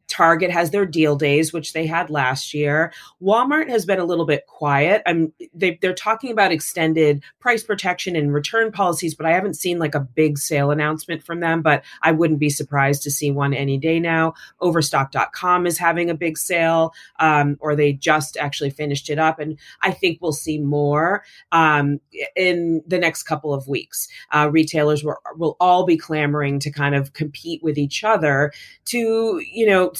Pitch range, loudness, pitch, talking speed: 150-175 Hz, -19 LUFS, 160 Hz, 185 wpm